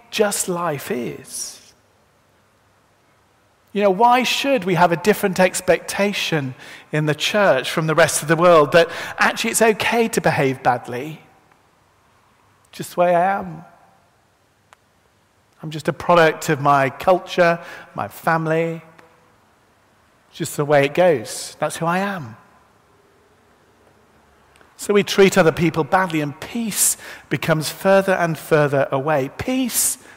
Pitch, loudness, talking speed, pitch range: 165 Hz, -18 LUFS, 130 wpm, 145-190 Hz